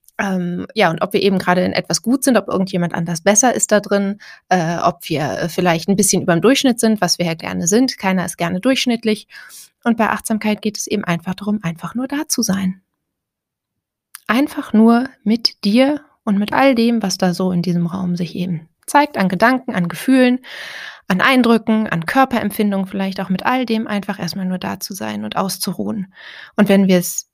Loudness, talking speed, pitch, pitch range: -17 LUFS, 200 wpm, 200 Hz, 180-230 Hz